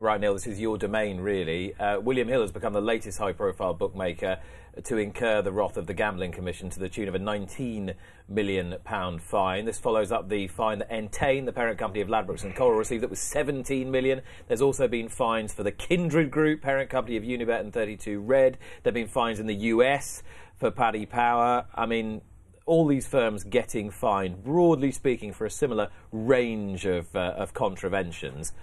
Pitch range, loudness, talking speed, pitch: 100-130 Hz, -27 LUFS, 195 wpm, 110 Hz